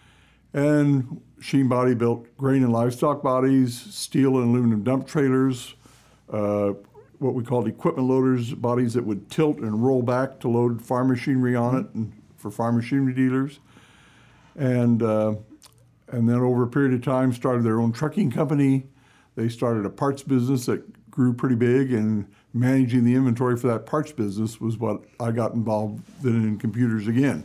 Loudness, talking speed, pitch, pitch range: -23 LUFS, 170 wpm, 125 Hz, 115-135 Hz